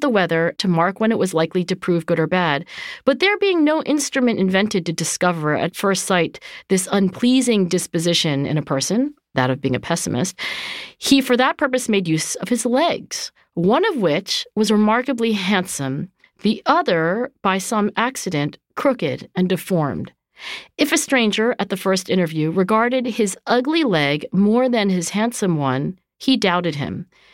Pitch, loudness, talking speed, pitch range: 195 Hz, -19 LUFS, 170 wpm, 170-240 Hz